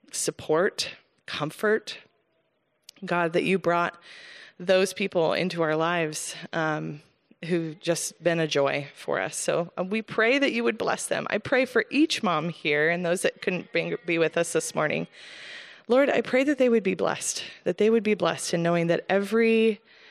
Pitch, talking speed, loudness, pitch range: 180 Hz, 175 wpm, -25 LUFS, 170-225 Hz